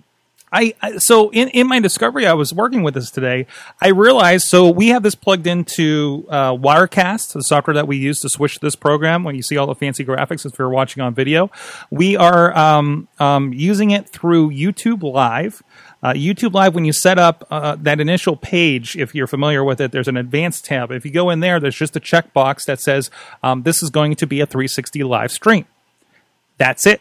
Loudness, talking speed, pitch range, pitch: -15 LUFS, 210 wpm, 140-185 Hz, 155 Hz